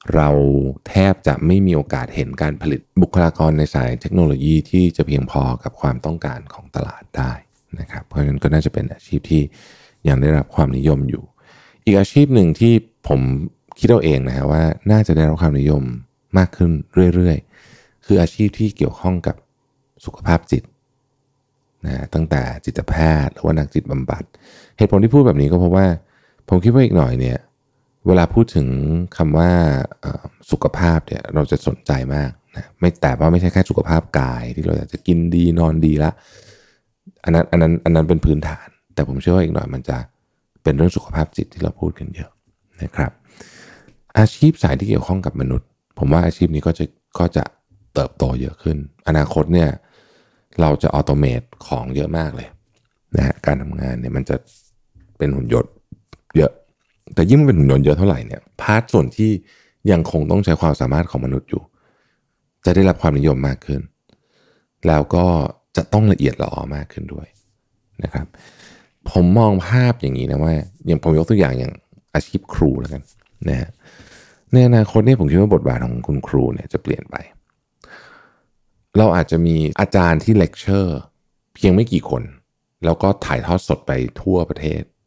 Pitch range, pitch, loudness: 75-100 Hz, 85 Hz, -17 LUFS